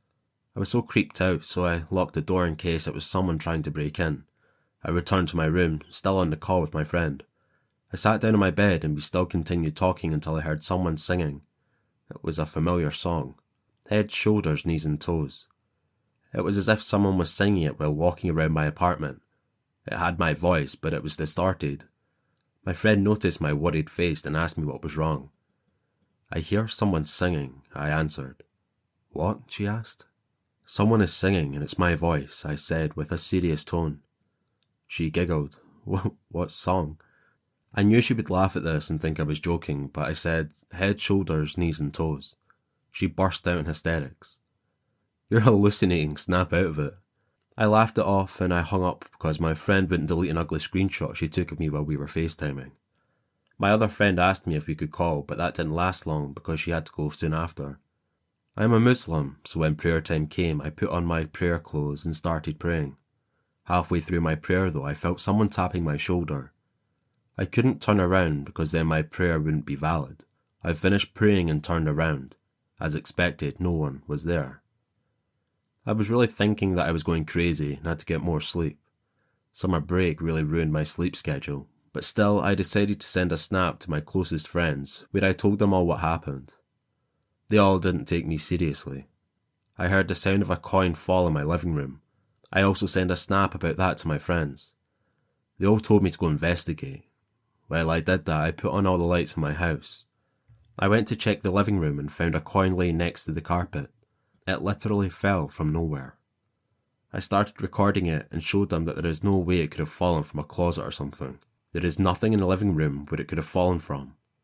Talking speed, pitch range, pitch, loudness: 205 wpm, 80-95 Hz, 85 Hz, -25 LUFS